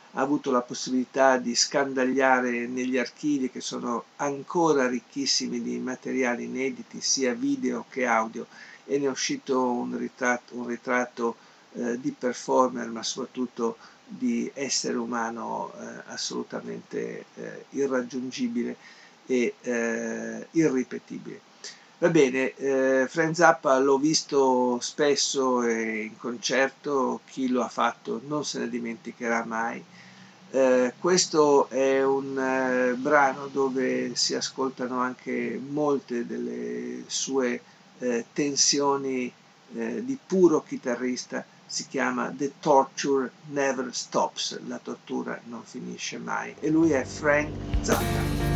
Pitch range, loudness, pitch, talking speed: 120-140 Hz, -26 LUFS, 130 Hz, 120 wpm